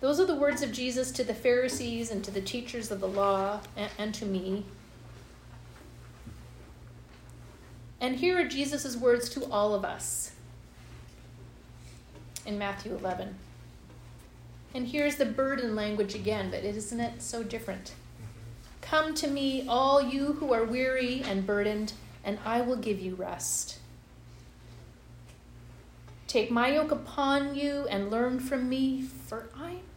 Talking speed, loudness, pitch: 140 wpm, -30 LUFS, 210 Hz